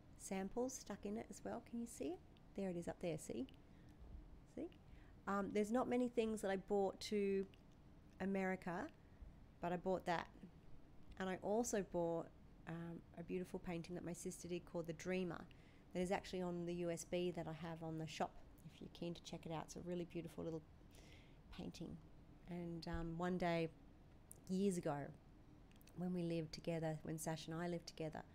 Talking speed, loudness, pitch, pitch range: 185 wpm, -46 LUFS, 175 Hz, 165-195 Hz